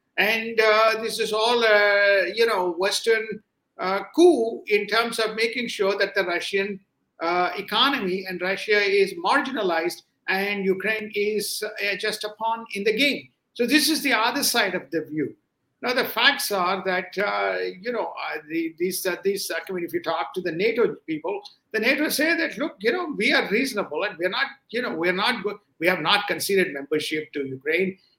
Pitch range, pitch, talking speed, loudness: 185-230 Hz, 205 Hz, 195 wpm, -23 LUFS